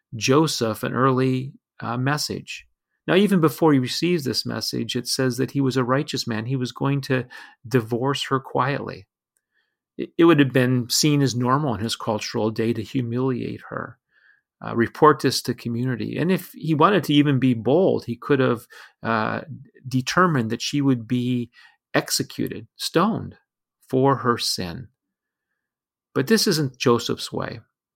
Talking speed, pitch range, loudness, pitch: 155 wpm, 120-145 Hz, -22 LUFS, 130 Hz